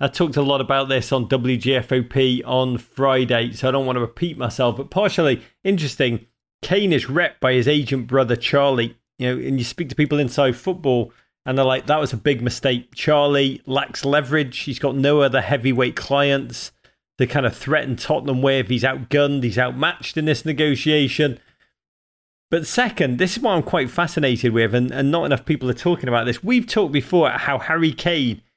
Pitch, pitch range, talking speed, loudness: 135 Hz, 125-150 Hz, 190 wpm, -20 LUFS